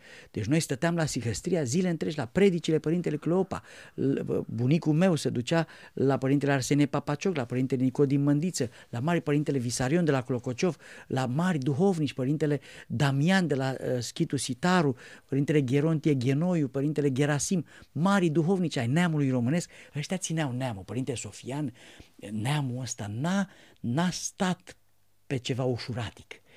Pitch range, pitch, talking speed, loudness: 130-170 Hz, 145 Hz, 140 wpm, -28 LUFS